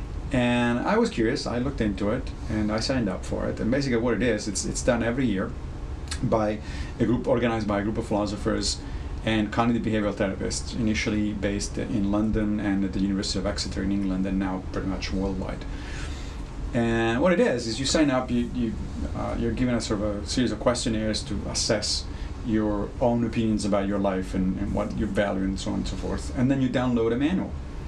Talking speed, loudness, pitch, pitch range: 215 wpm, -26 LUFS, 105 Hz, 95-115 Hz